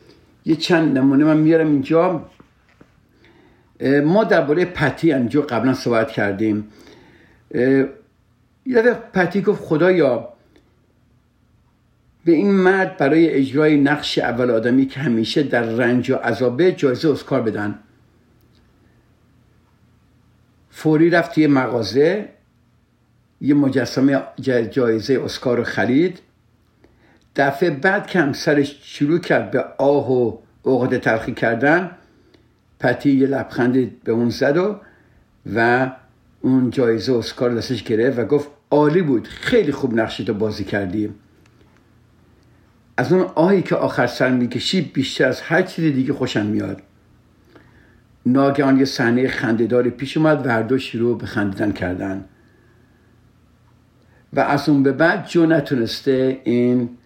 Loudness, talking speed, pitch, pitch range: -18 LUFS, 120 wpm, 125 Hz, 115-145 Hz